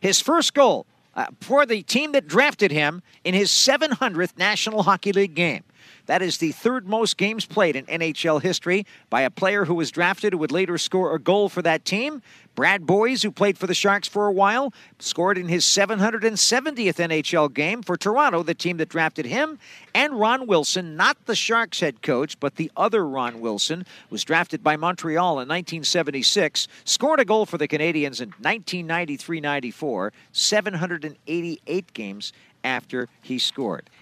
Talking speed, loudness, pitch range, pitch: 170 wpm, -22 LUFS, 160-210 Hz, 185 Hz